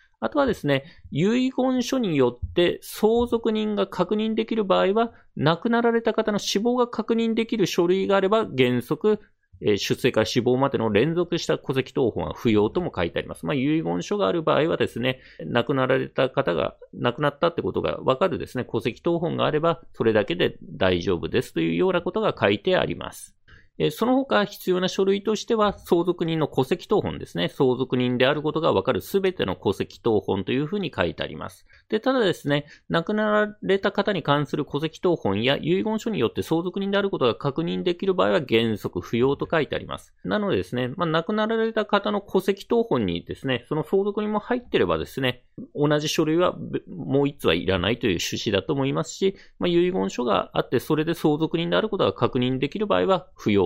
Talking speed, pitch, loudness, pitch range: 400 characters per minute, 170 Hz, -24 LUFS, 135-210 Hz